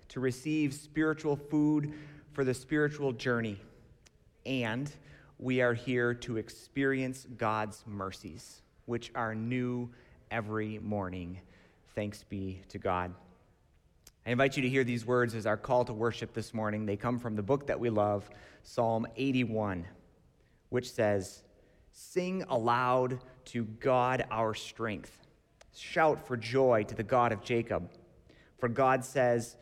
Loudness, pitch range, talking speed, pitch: -33 LUFS, 105-130 Hz, 140 wpm, 120 Hz